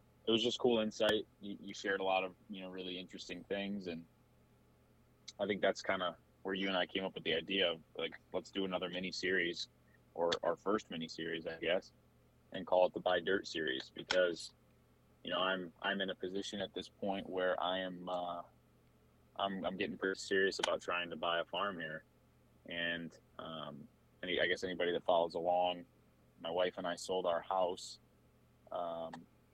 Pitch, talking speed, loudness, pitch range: 90 Hz, 195 wpm, -38 LUFS, 85-95 Hz